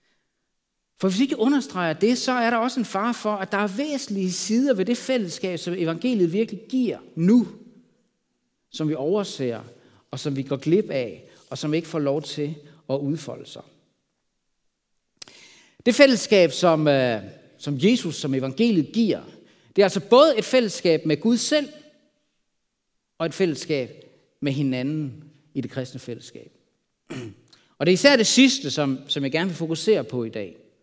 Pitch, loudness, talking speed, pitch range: 175 Hz, -22 LUFS, 165 wpm, 145-230 Hz